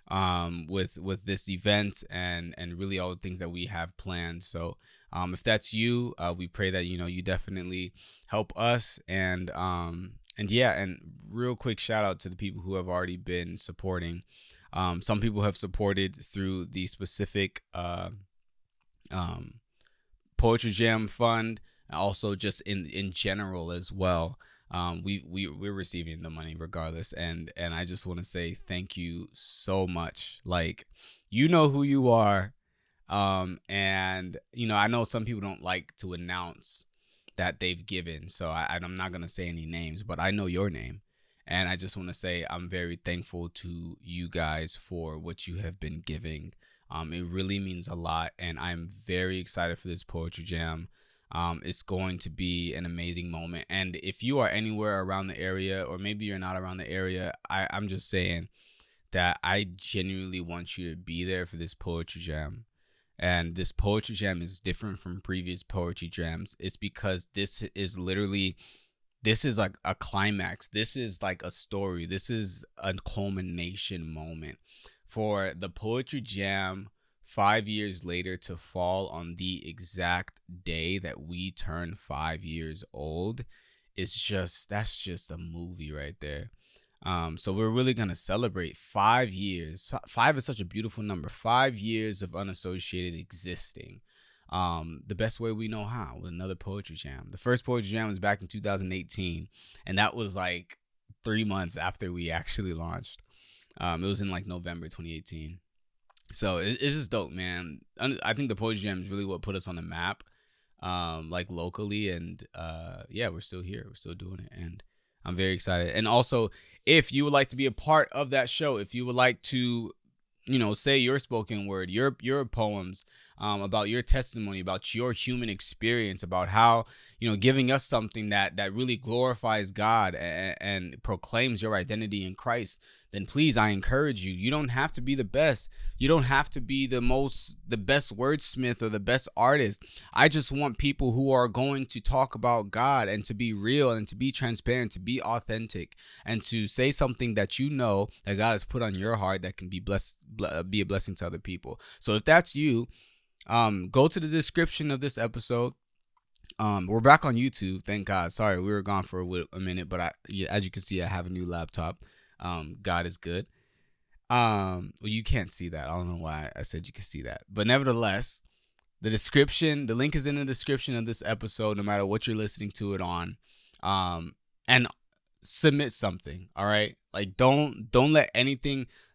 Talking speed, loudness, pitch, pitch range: 185 wpm, -30 LUFS, 95 Hz, 90-110 Hz